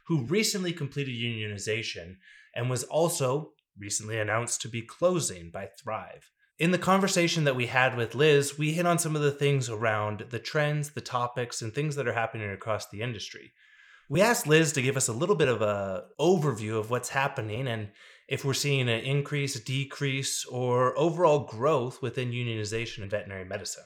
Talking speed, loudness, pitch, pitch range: 180 wpm, -28 LUFS, 130 Hz, 115-145 Hz